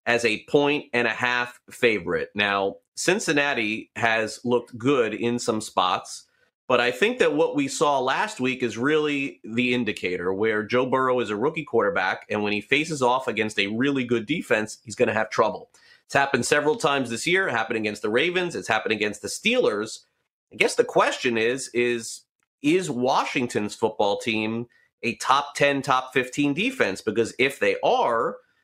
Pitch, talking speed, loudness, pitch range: 125 Hz, 180 wpm, -23 LUFS, 110-145 Hz